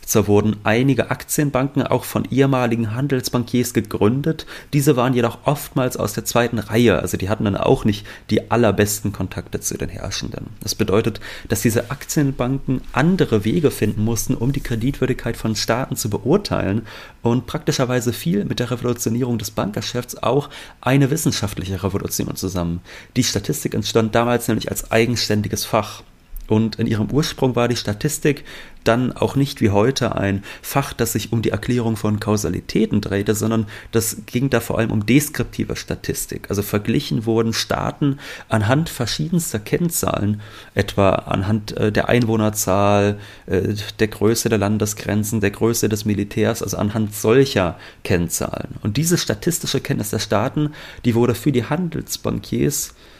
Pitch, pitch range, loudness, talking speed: 115 Hz, 105-130 Hz, -20 LUFS, 150 wpm